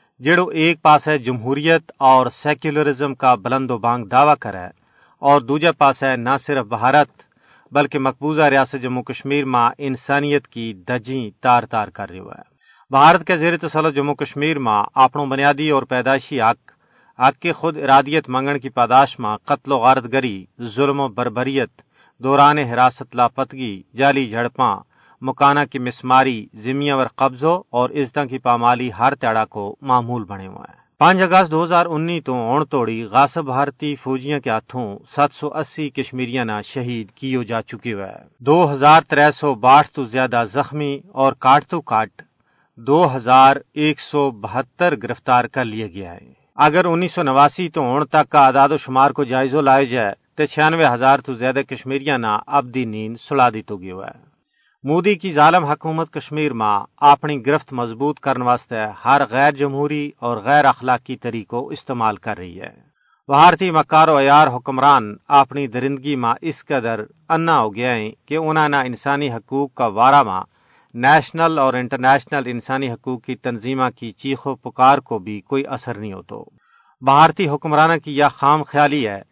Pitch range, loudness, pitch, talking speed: 120-145 Hz, -17 LUFS, 135 Hz, 165 wpm